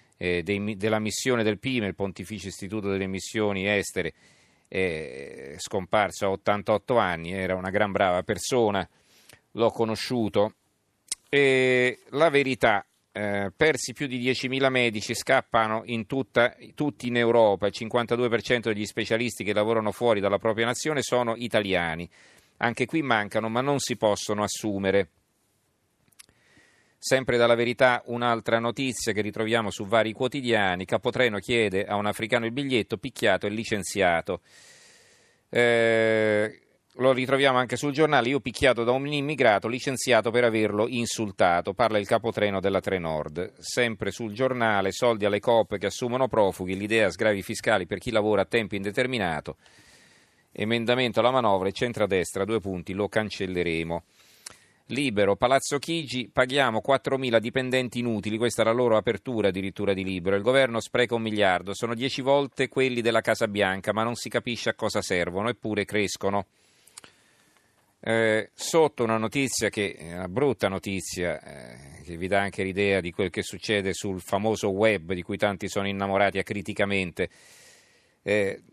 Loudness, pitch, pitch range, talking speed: -25 LUFS, 110 Hz, 100-125 Hz, 145 wpm